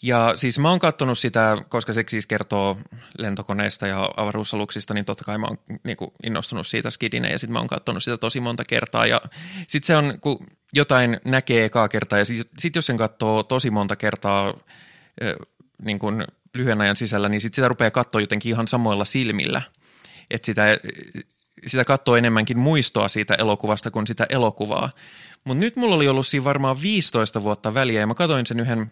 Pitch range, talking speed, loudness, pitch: 105-130 Hz, 185 wpm, -21 LUFS, 115 Hz